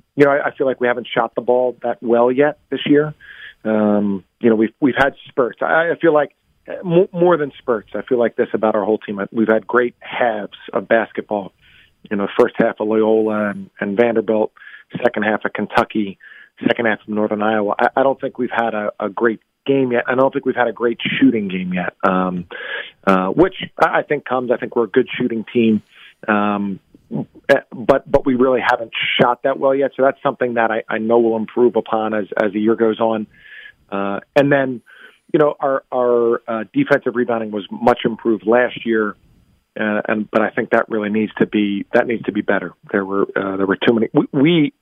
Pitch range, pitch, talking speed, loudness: 105-130 Hz, 115 Hz, 215 wpm, -18 LUFS